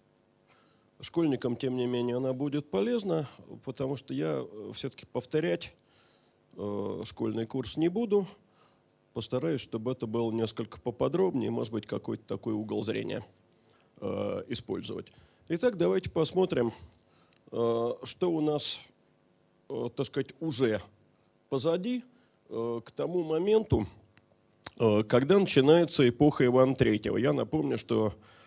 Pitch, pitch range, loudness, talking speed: 125 Hz, 110-155 Hz, -30 LUFS, 105 wpm